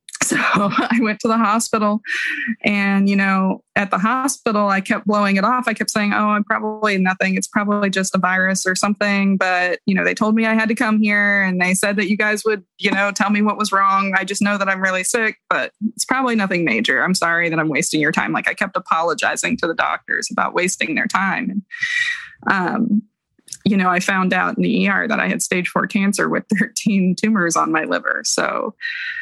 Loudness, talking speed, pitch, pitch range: -18 LUFS, 225 wpm, 205 Hz, 190-220 Hz